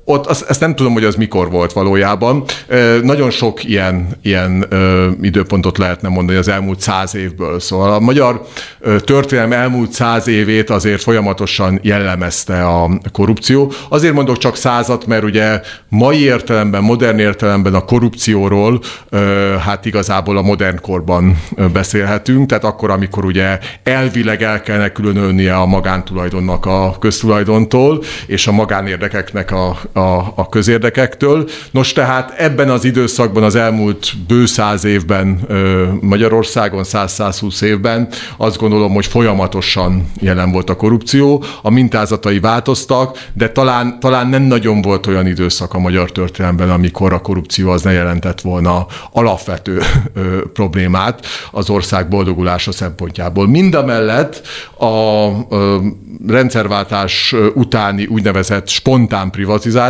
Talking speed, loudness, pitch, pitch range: 130 wpm, -13 LUFS, 105 Hz, 95-120 Hz